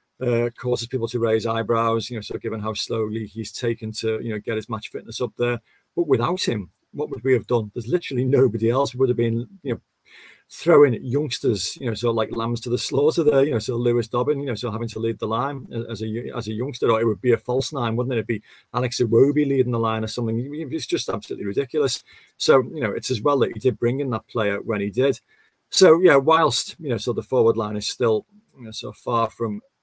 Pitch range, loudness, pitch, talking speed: 115-130 Hz, -22 LUFS, 120 Hz, 270 wpm